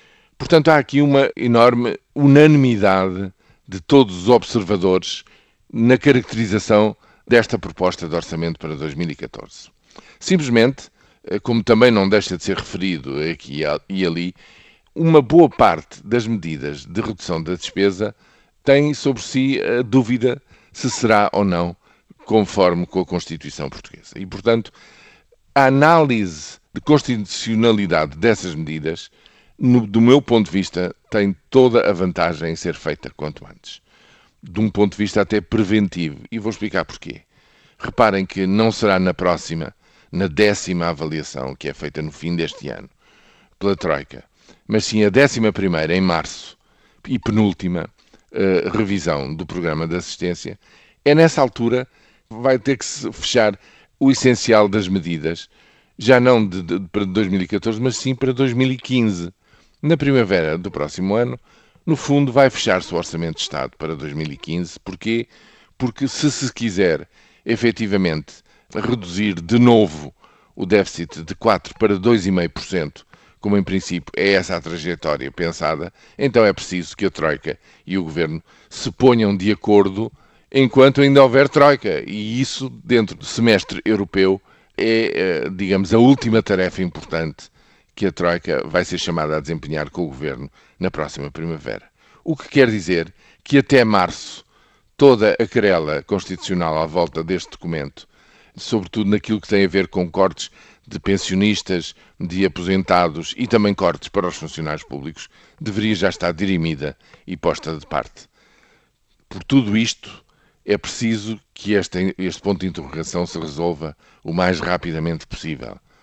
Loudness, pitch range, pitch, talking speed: -18 LUFS, 85-120 Hz, 100 Hz, 145 wpm